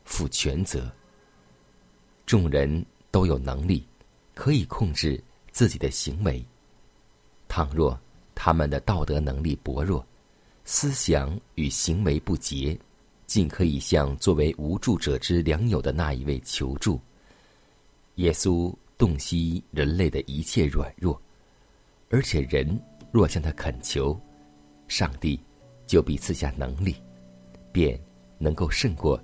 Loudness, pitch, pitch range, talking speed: -26 LUFS, 75 Hz, 70-85 Hz, 175 characters per minute